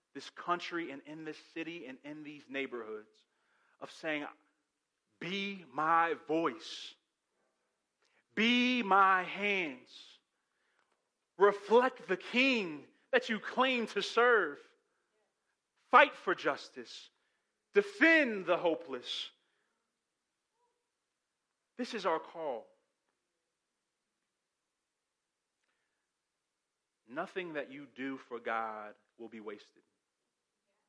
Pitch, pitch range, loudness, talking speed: 185 Hz, 145-245 Hz, -32 LUFS, 85 wpm